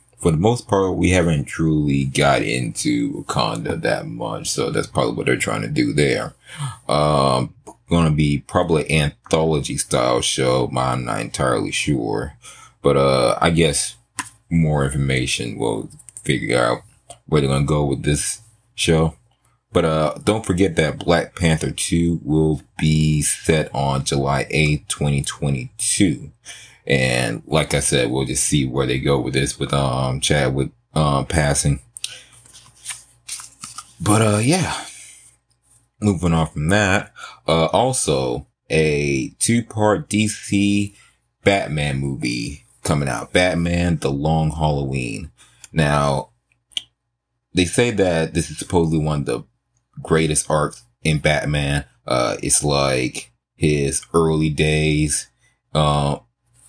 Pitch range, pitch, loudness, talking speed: 70-100 Hz, 80 Hz, -19 LUFS, 135 wpm